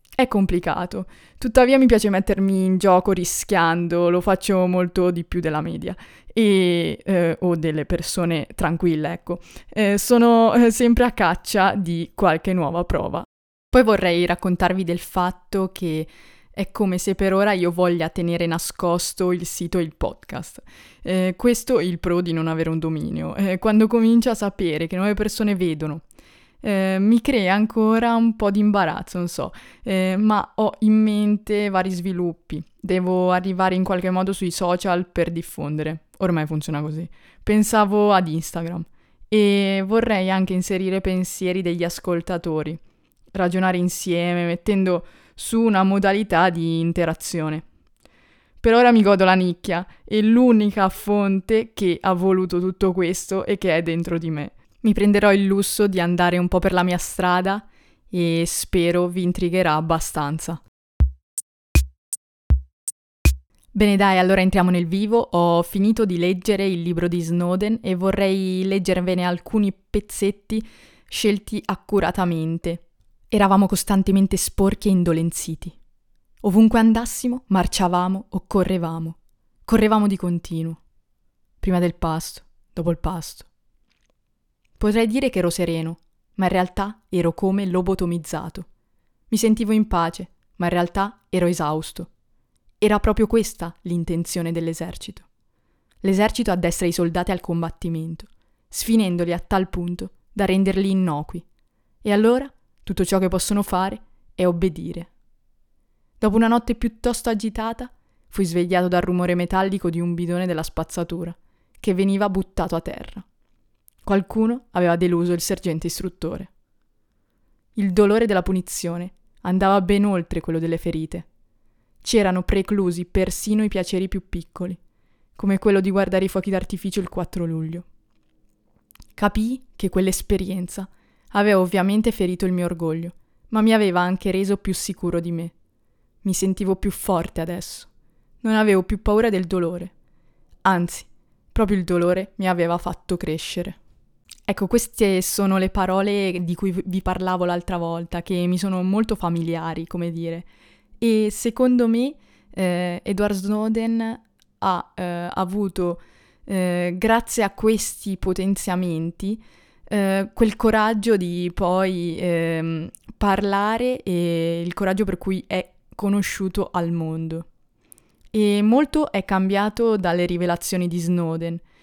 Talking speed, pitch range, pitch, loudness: 135 wpm, 175-200 Hz, 185 Hz, -21 LUFS